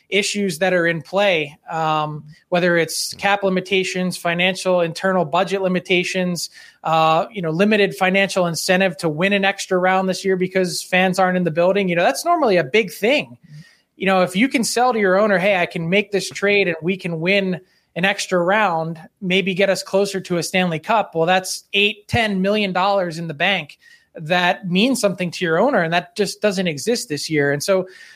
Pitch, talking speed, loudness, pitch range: 185 Hz, 200 wpm, -18 LUFS, 175-200 Hz